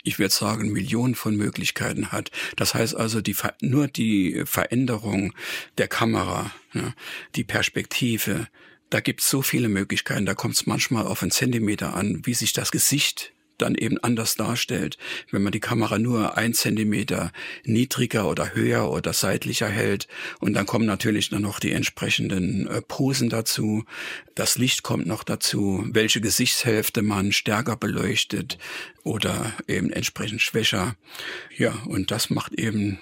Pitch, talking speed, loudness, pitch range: 110 Hz, 150 wpm, -24 LUFS, 105-120 Hz